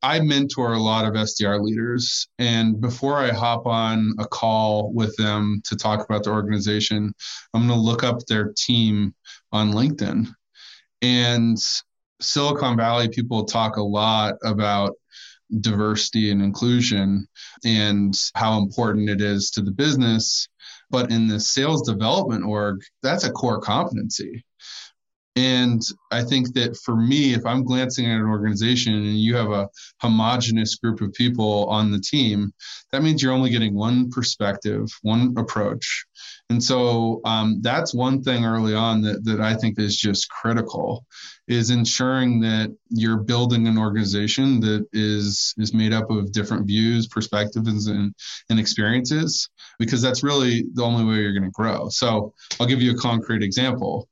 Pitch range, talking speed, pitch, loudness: 105-120 Hz, 155 wpm, 110 Hz, -21 LUFS